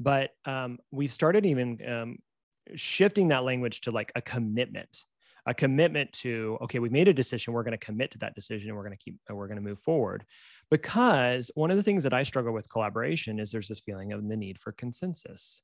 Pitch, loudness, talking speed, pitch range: 120 Hz, -29 LUFS, 205 wpm, 110-140 Hz